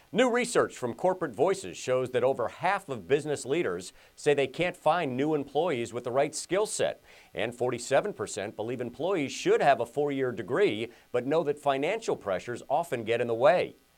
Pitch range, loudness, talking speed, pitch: 125-160 Hz, -29 LUFS, 185 wpm, 140 Hz